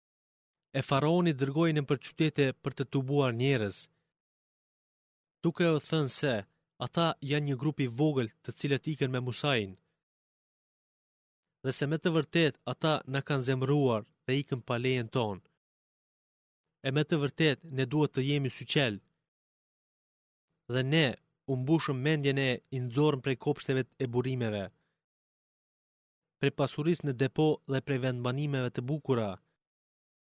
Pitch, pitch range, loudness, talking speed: 140 Hz, 130-155 Hz, -31 LUFS, 135 wpm